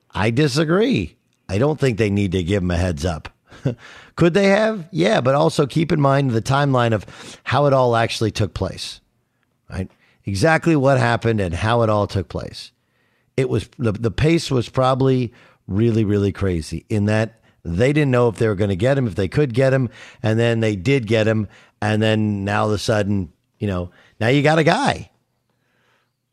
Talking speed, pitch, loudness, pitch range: 200 wpm, 115 Hz, -19 LUFS, 105-135 Hz